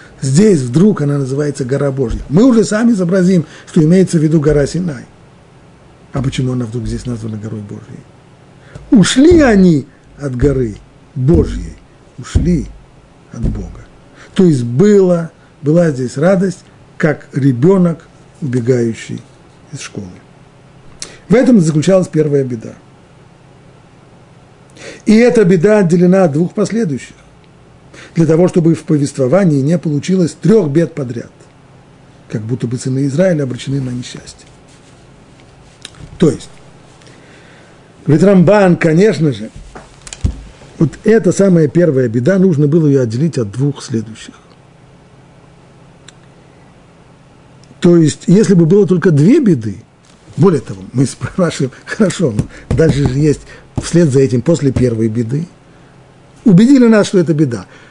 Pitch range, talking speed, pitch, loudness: 135-175 Hz, 125 wpm, 145 Hz, -12 LUFS